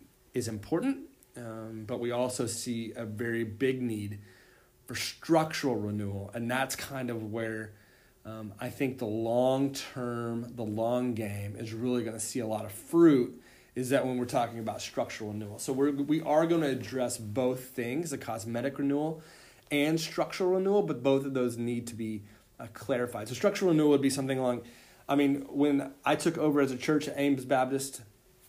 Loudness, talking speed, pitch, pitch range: -31 LUFS, 185 wpm, 125 Hz, 115-140 Hz